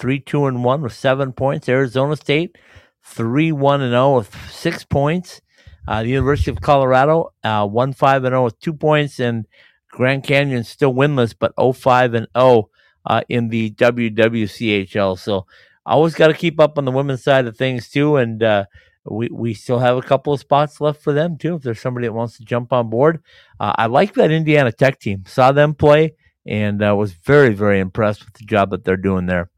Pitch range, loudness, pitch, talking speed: 115-145 Hz, -17 LUFS, 130 Hz, 215 wpm